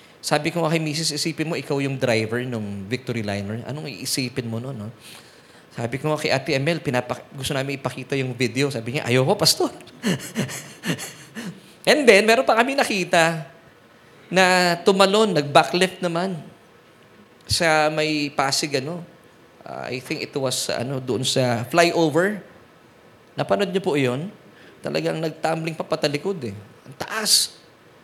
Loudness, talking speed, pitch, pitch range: -21 LUFS, 145 wpm, 150 Hz, 125-165 Hz